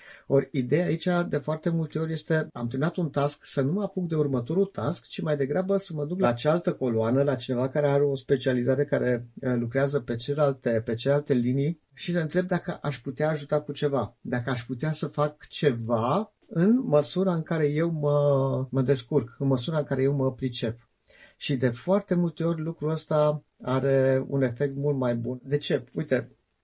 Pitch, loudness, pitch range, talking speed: 145 Hz, -27 LUFS, 130-160 Hz, 195 wpm